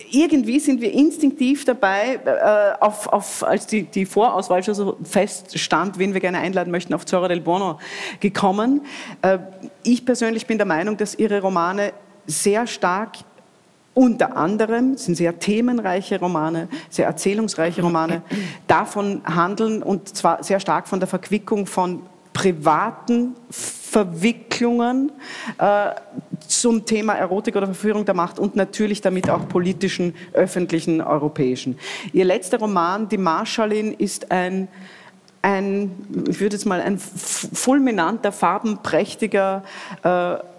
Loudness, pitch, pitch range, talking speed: -20 LUFS, 195 Hz, 180-220 Hz, 130 wpm